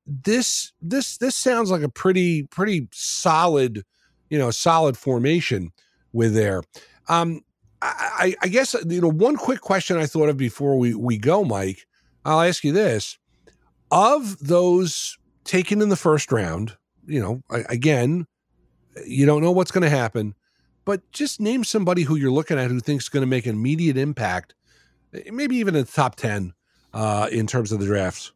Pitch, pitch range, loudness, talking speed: 150 Hz, 115-185 Hz, -21 LUFS, 165 wpm